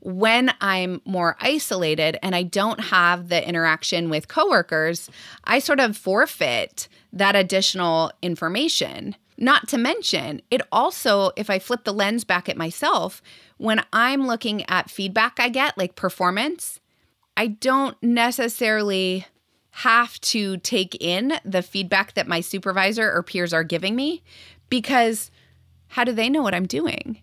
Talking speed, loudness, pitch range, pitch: 145 wpm, -21 LUFS, 180-240 Hz, 200 Hz